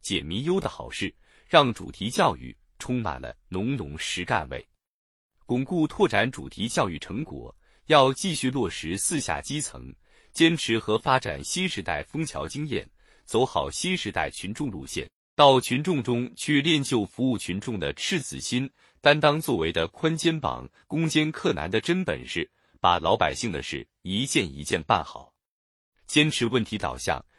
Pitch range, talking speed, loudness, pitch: 100-155 Hz, 235 characters per minute, -26 LUFS, 130 Hz